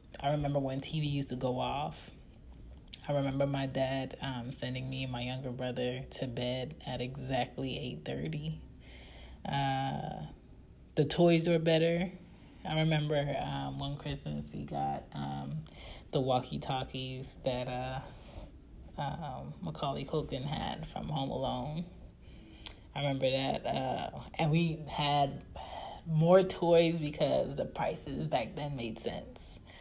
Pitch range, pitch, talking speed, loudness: 125-150 Hz, 135 Hz, 135 wpm, -34 LUFS